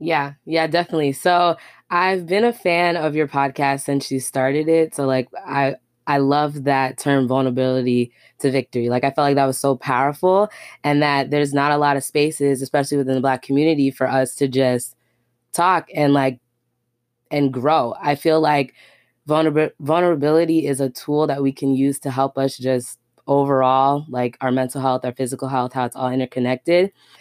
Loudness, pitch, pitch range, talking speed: -19 LUFS, 140 Hz, 130-150 Hz, 185 wpm